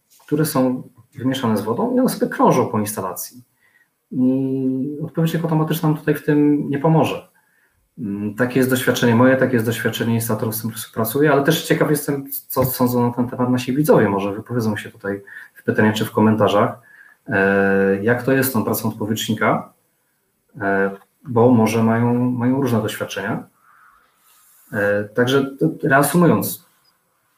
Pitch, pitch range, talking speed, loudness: 125 Hz, 110-140 Hz, 145 wpm, -19 LUFS